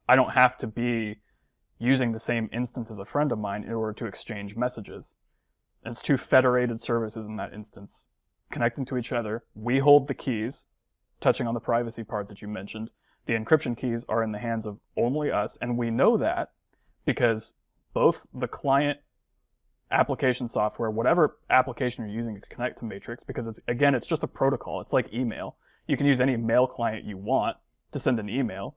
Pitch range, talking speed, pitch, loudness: 110-125 Hz, 195 wpm, 115 Hz, -27 LUFS